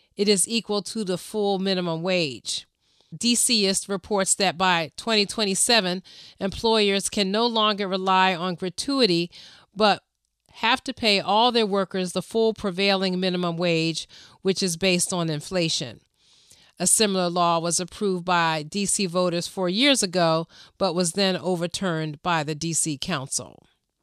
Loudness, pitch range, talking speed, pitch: -23 LUFS, 175-205 Hz, 140 wpm, 185 Hz